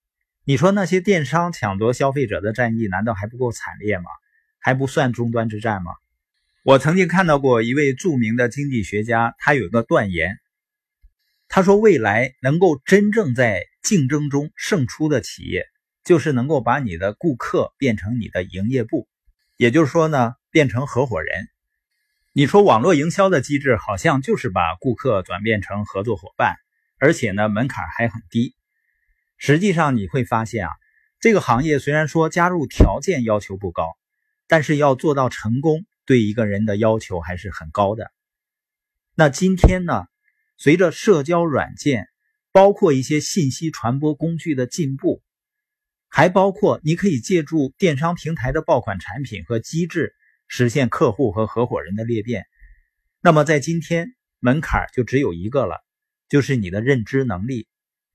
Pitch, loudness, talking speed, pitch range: 135 Hz, -19 LUFS, 250 characters per minute, 115-165 Hz